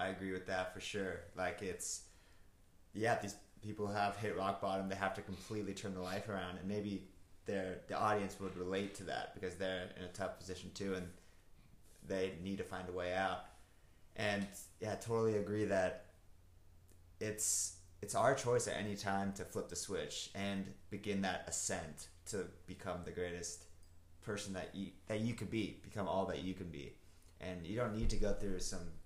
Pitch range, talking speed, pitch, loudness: 90-100 Hz, 190 wpm, 95 Hz, -41 LUFS